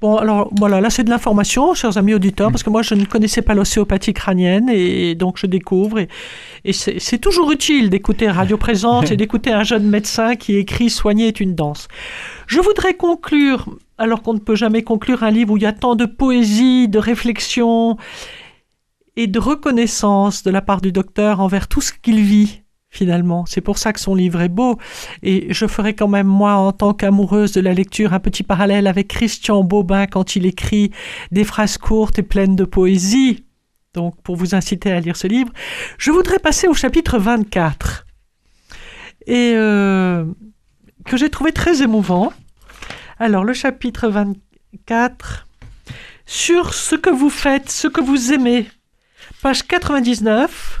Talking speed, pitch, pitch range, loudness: 175 wpm, 215 Hz, 195-245 Hz, -16 LUFS